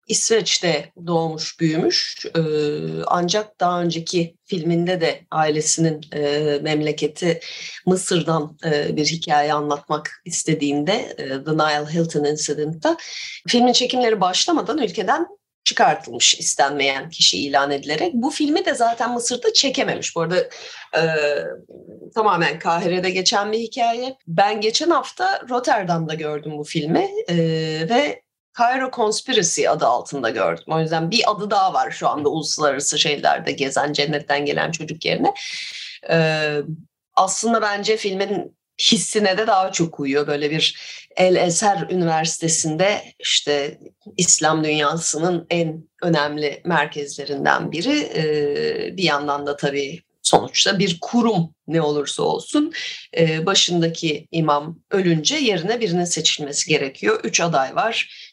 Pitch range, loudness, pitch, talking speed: 150-215 Hz, -20 LUFS, 165 Hz, 120 wpm